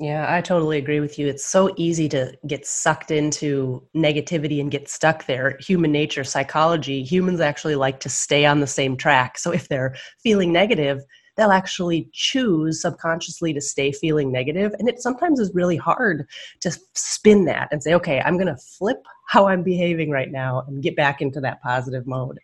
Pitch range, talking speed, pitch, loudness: 140-175 Hz, 190 wpm, 155 Hz, -21 LUFS